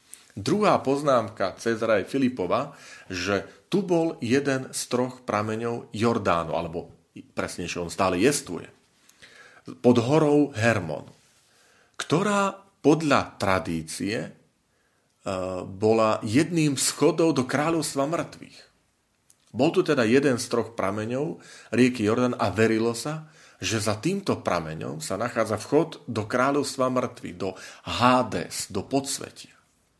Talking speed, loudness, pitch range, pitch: 110 wpm, -25 LUFS, 100-145 Hz, 120 Hz